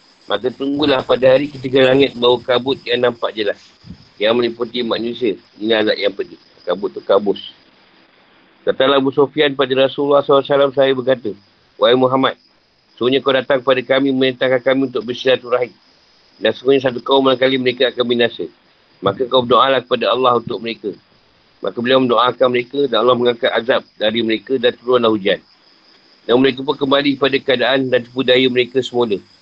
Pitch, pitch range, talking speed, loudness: 130 Hz, 120-135 Hz, 165 wpm, -16 LUFS